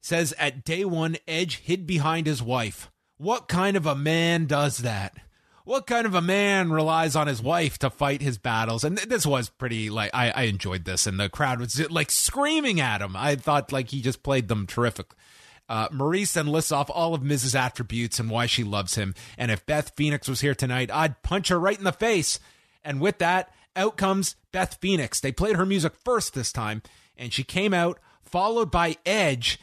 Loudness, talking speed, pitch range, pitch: -25 LUFS, 210 wpm, 120-175 Hz, 145 Hz